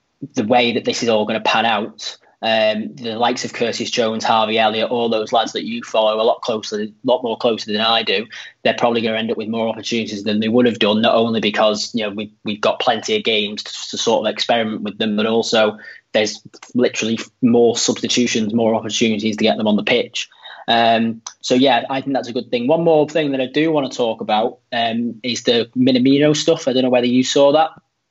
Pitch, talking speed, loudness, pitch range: 115 Hz, 235 wpm, -17 LUFS, 110-130 Hz